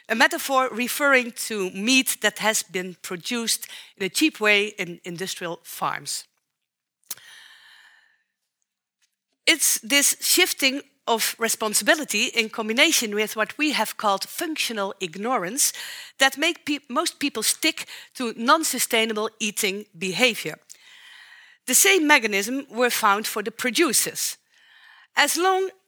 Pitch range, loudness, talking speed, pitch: 215-315 Hz, -21 LUFS, 120 wpm, 245 Hz